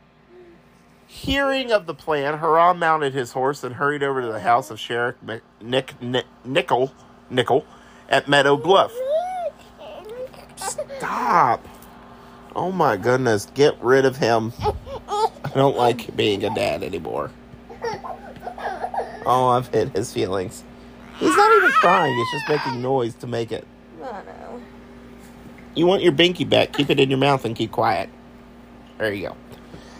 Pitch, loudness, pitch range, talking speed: 140 Hz, -20 LUFS, 125-175 Hz, 140 wpm